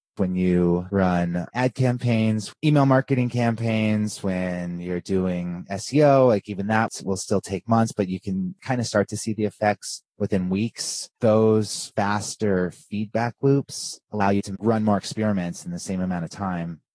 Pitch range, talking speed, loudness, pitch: 95-115 Hz, 165 wpm, -23 LUFS, 105 Hz